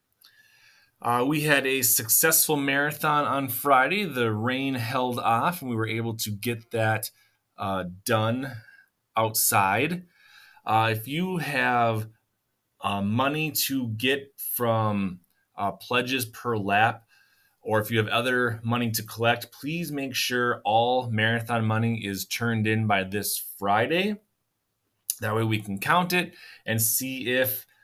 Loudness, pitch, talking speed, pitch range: -25 LUFS, 120 Hz, 140 wpm, 110-135 Hz